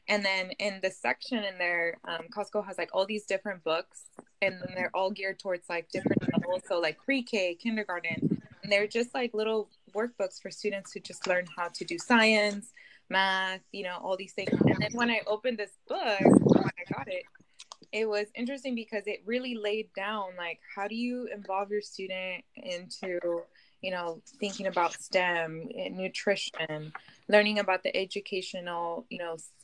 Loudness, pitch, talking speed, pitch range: -30 LUFS, 195 Hz, 180 wpm, 180-215 Hz